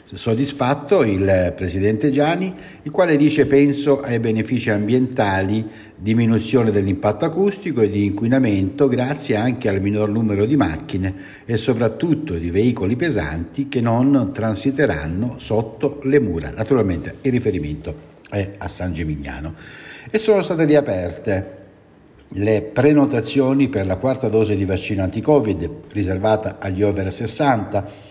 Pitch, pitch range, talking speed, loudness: 110 Hz, 100-140 Hz, 125 wpm, -19 LUFS